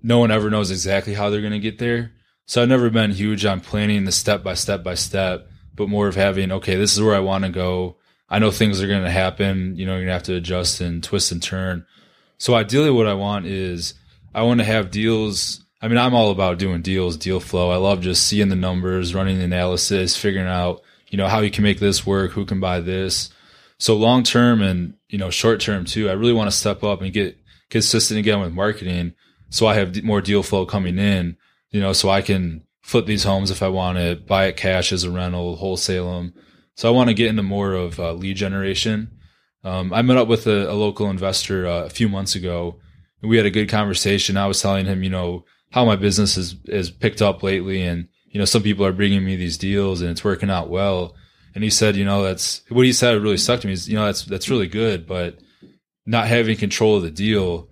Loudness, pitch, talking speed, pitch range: -19 LUFS, 100 Hz, 245 wpm, 90-105 Hz